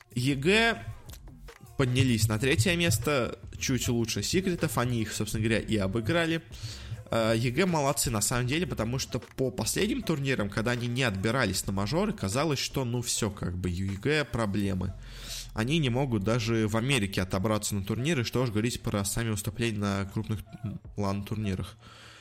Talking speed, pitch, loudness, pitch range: 150 wpm, 115 Hz, -29 LUFS, 110-135 Hz